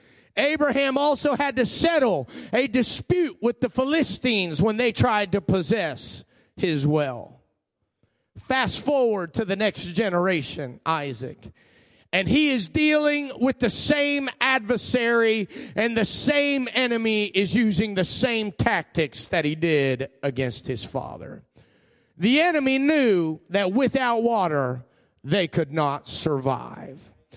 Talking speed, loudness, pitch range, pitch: 125 wpm, -23 LUFS, 160-260 Hz, 220 Hz